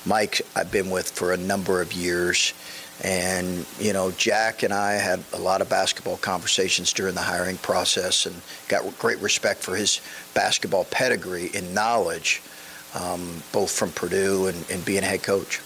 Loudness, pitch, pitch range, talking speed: -24 LUFS, 90 Hz, 85-95 Hz, 170 wpm